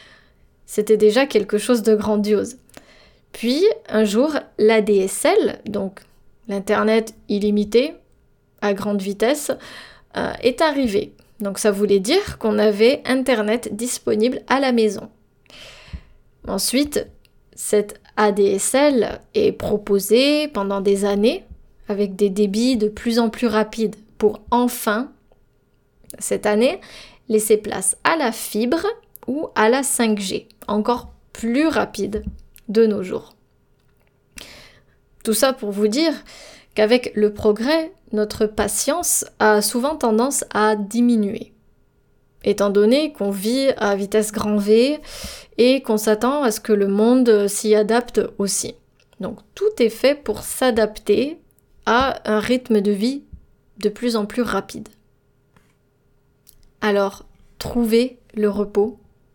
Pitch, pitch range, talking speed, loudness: 220 Hz, 210-245 Hz, 120 wpm, -19 LUFS